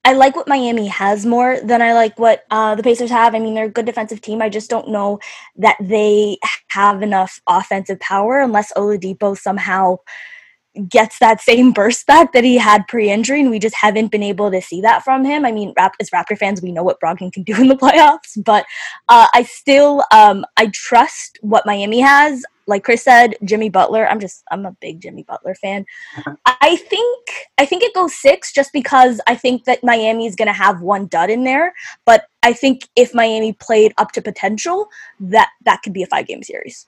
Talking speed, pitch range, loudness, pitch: 210 wpm, 205-260 Hz, -13 LUFS, 225 Hz